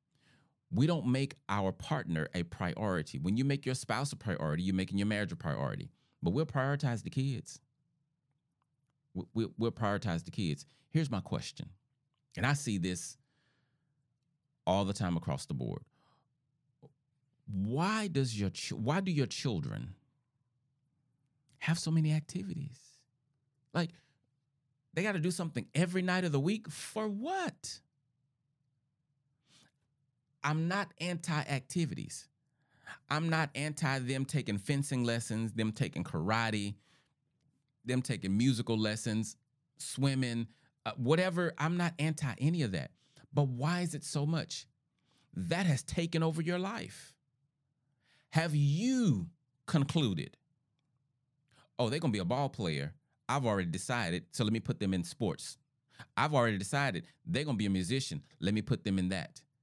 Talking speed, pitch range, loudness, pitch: 140 wpm, 125-155 Hz, -34 LUFS, 140 Hz